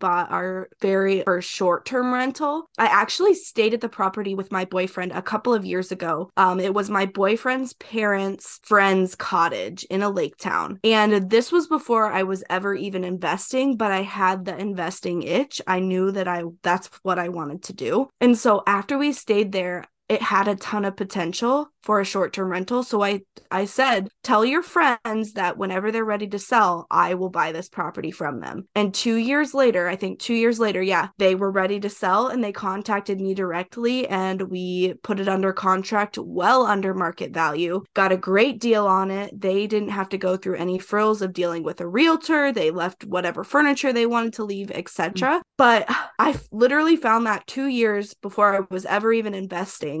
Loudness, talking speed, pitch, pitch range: -22 LUFS, 200 wpm, 200 Hz, 185-225 Hz